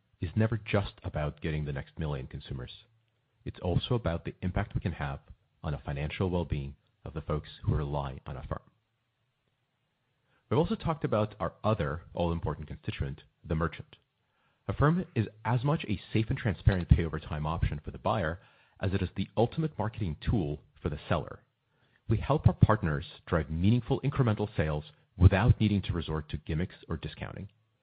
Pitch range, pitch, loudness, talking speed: 80-120 Hz, 100 Hz, -31 LUFS, 175 wpm